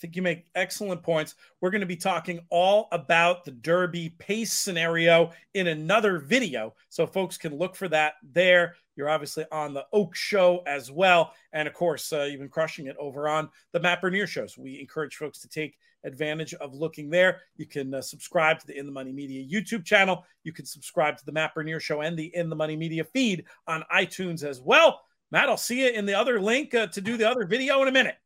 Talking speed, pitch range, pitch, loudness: 225 wpm, 155-190 Hz, 170 Hz, -25 LUFS